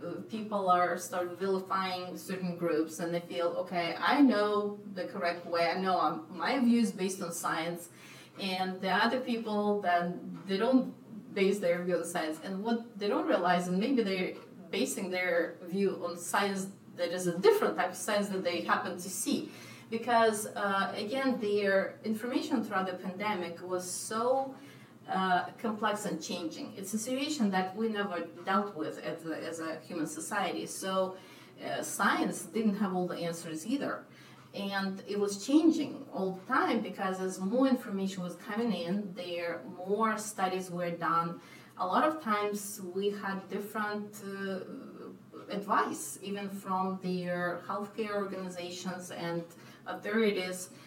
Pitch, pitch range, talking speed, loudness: 190 Hz, 175-215 Hz, 155 wpm, -32 LUFS